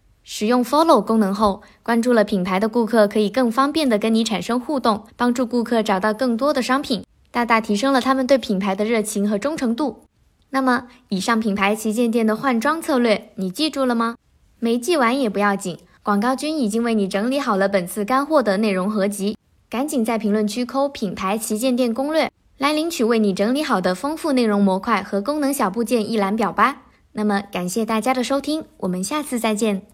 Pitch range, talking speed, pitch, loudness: 210-260 Hz, 320 characters per minute, 230 Hz, -20 LUFS